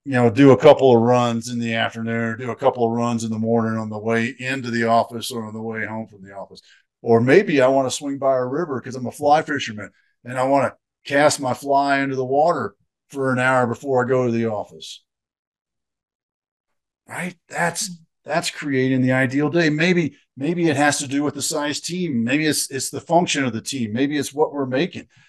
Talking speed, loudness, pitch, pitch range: 230 wpm, -20 LUFS, 130 Hz, 115-145 Hz